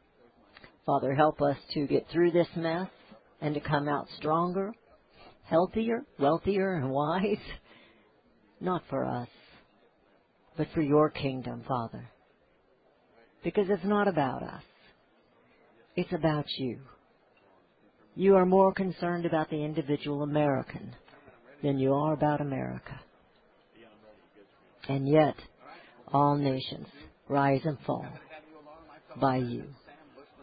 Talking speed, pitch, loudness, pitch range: 110 wpm, 150 Hz, -29 LUFS, 140-175 Hz